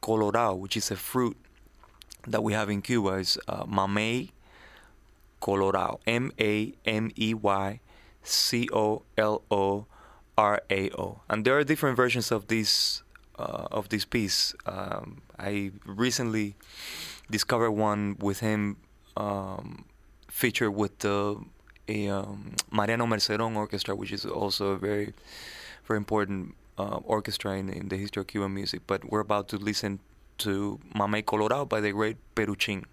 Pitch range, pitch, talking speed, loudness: 100-110 Hz, 105 Hz, 145 wpm, -29 LUFS